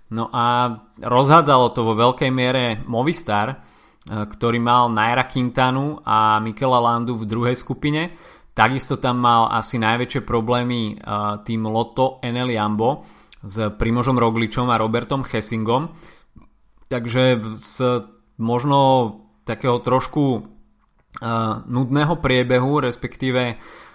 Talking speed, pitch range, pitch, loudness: 105 wpm, 115-130 Hz, 120 Hz, -20 LUFS